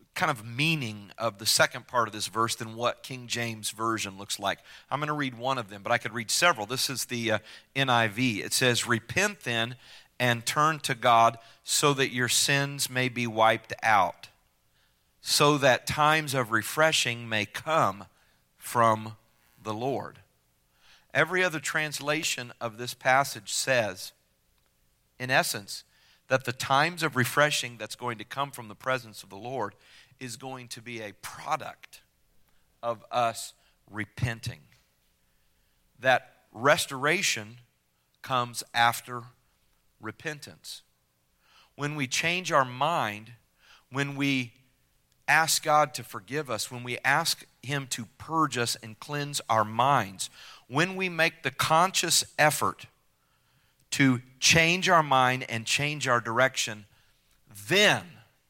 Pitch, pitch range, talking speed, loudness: 120 Hz, 110-140 Hz, 140 wpm, -26 LUFS